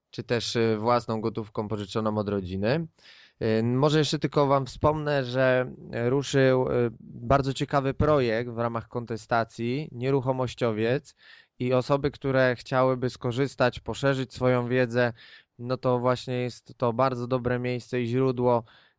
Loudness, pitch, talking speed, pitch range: -26 LUFS, 125 Hz, 125 wpm, 115-135 Hz